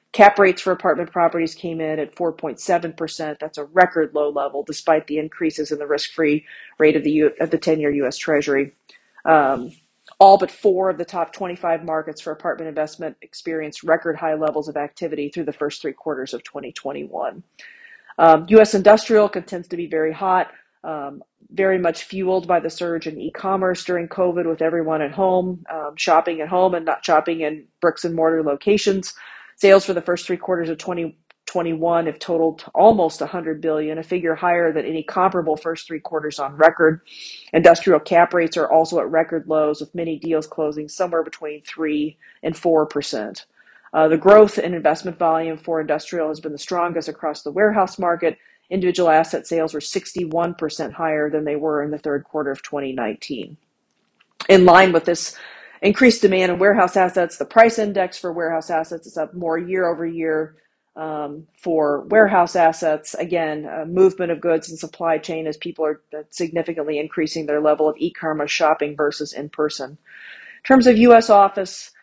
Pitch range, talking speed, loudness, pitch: 155-180 Hz, 180 wpm, -19 LUFS, 165 Hz